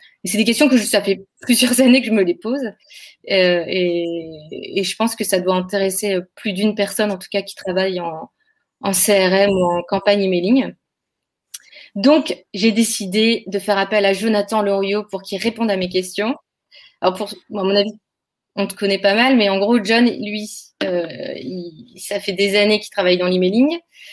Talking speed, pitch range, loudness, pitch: 195 wpm, 190-225 Hz, -17 LUFS, 200 Hz